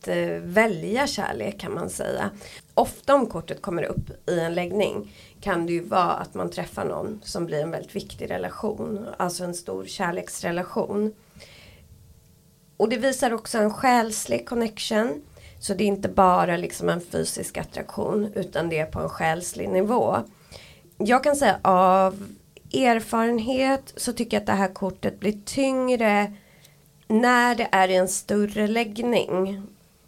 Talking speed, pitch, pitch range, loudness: 150 wpm, 200 Hz, 170-220 Hz, -24 LUFS